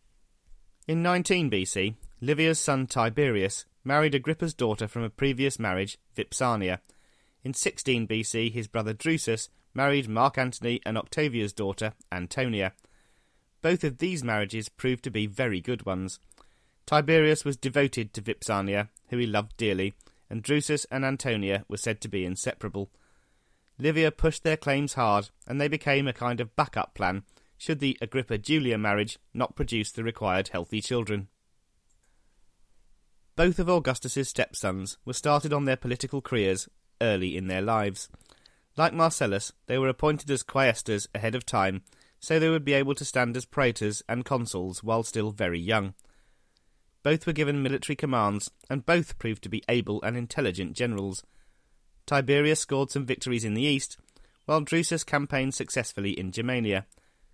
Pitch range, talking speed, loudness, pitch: 105-140 Hz, 150 wpm, -28 LUFS, 120 Hz